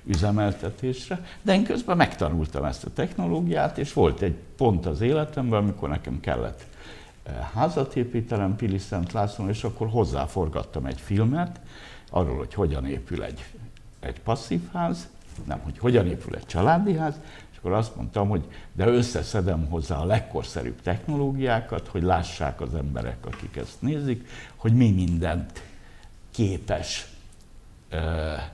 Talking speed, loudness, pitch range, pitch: 135 wpm, -26 LUFS, 85-120 Hz, 100 Hz